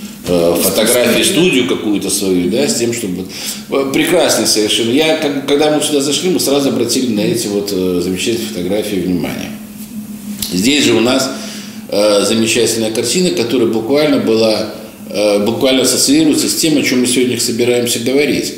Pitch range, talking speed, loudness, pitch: 105-150 Hz, 140 wpm, -13 LUFS, 120 Hz